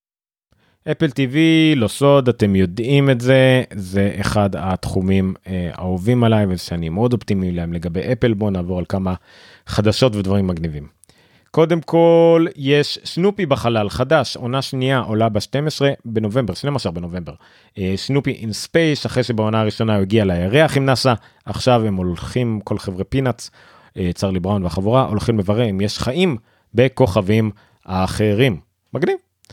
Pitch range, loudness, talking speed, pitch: 95-135 Hz, -18 LUFS, 145 wpm, 110 Hz